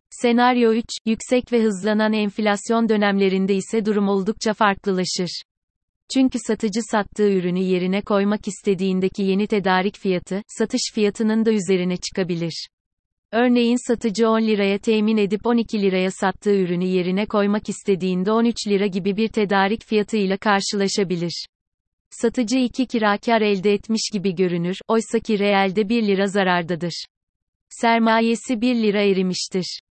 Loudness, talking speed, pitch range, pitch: -20 LUFS, 125 wpm, 190-225 Hz, 205 Hz